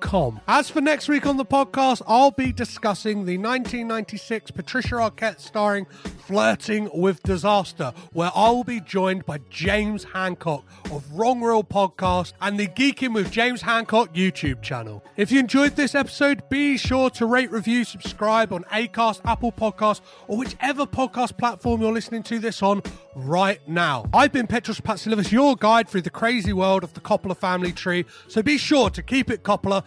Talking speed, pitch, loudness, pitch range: 175 wpm, 215 Hz, -22 LUFS, 190-245 Hz